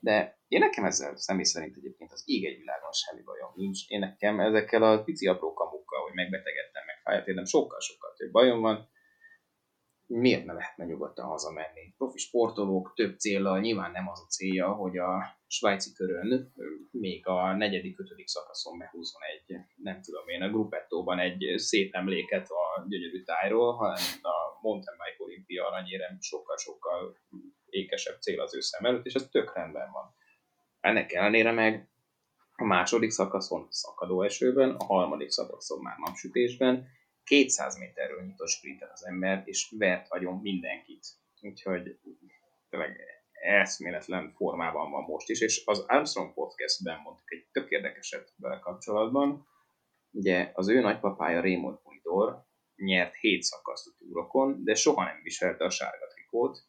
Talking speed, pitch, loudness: 145 wpm, 115 Hz, -30 LUFS